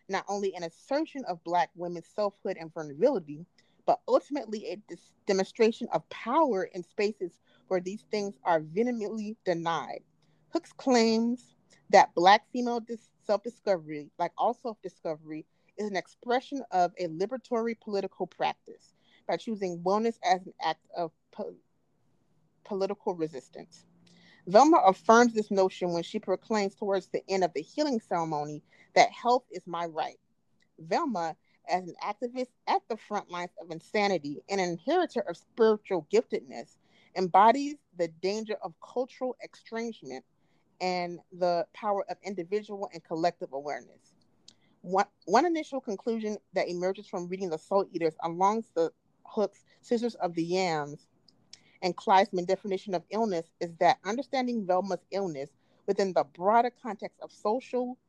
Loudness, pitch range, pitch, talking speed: -30 LUFS, 175-225 Hz, 195 Hz, 145 wpm